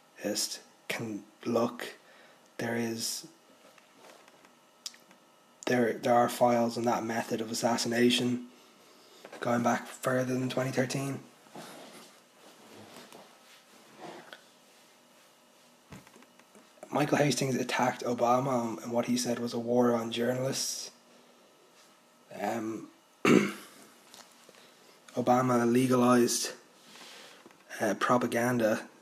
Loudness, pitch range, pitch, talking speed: -30 LUFS, 120-125 Hz, 120 Hz, 75 wpm